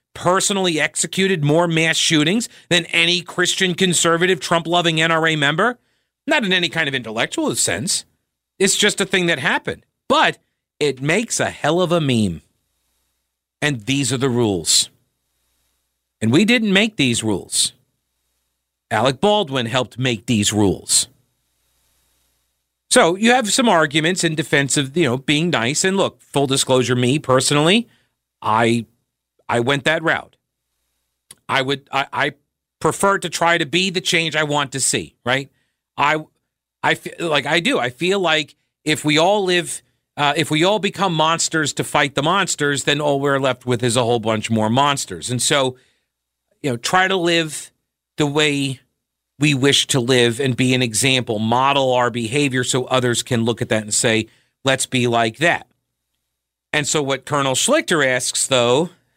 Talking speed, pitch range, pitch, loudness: 165 wpm, 120-165 Hz, 140 Hz, -17 LUFS